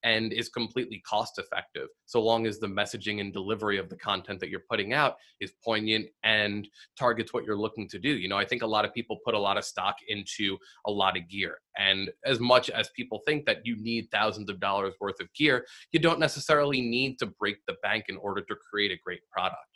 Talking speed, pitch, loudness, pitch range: 230 wpm, 110 Hz, -29 LUFS, 100-120 Hz